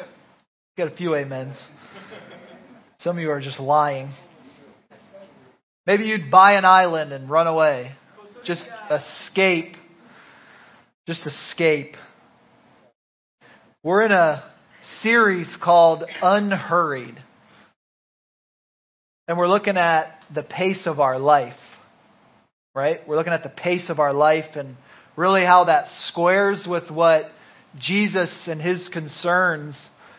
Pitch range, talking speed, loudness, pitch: 150-185 Hz, 115 wpm, -20 LUFS, 170 Hz